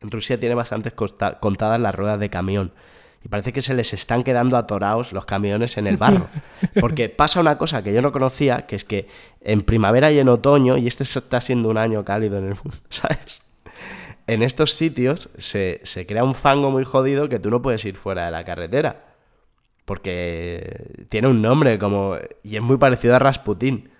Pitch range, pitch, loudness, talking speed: 105-130 Hz, 120 Hz, -20 LUFS, 200 wpm